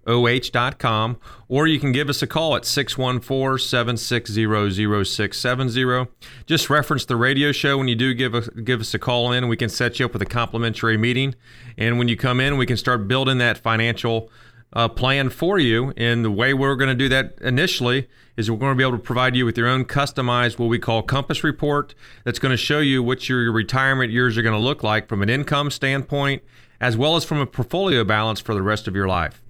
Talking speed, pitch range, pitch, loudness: 220 wpm, 115-135 Hz, 125 Hz, -20 LUFS